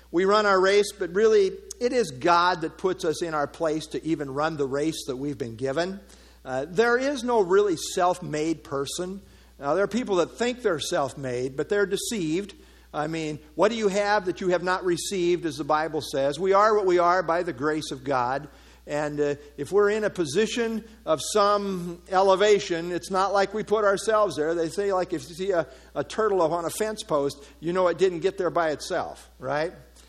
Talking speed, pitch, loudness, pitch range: 210 wpm, 180 Hz, -25 LUFS, 155-205 Hz